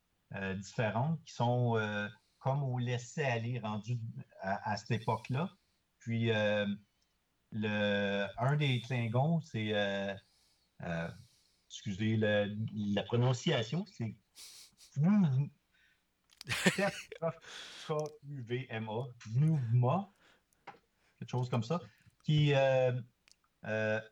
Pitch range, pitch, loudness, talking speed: 110-140 Hz, 120 Hz, -35 LUFS, 95 wpm